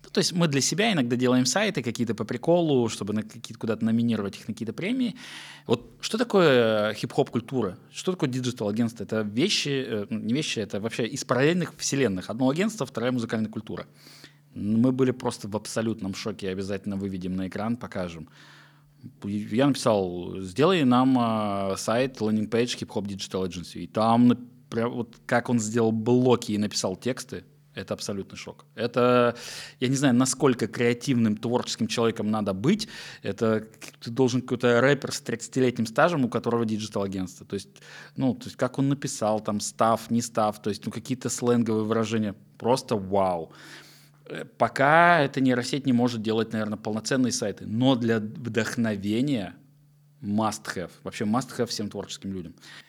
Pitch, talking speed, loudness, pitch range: 115 Hz, 160 wpm, -26 LUFS, 110-130 Hz